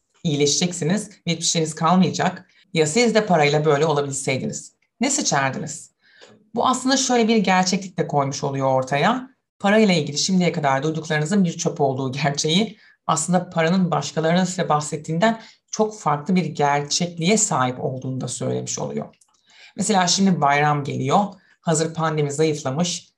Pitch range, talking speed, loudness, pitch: 145-195 Hz, 130 wpm, -20 LUFS, 160 Hz